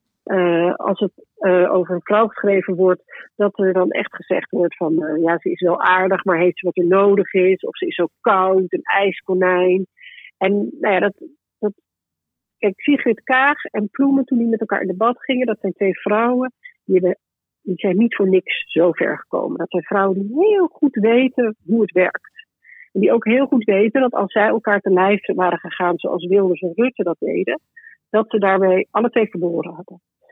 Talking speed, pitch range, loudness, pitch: 205 wpm, 180-235 Hz, -18 LUFS, 195 Hz